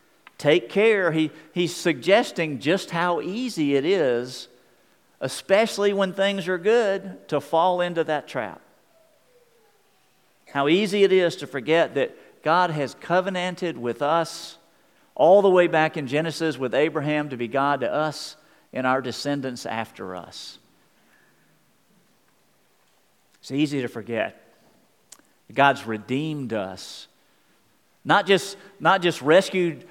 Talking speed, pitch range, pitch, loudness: 125 wpm, 140-195 Hz, 165 Hz, -23 LUFS